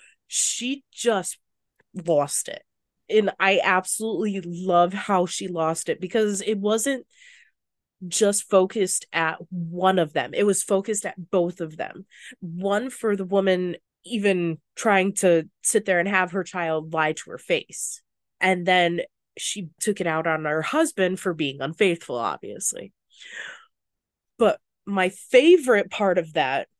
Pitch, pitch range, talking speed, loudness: 190 Hz, 175-210 Hz, 145 wpm, -23 LUFS